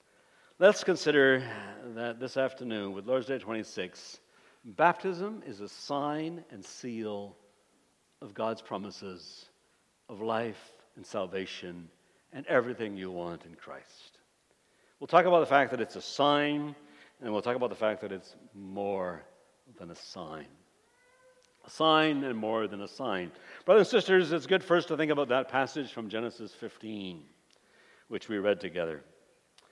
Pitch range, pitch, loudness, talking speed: 105-155 Hz, 125 Hz, -30 LUFS, 150 wpm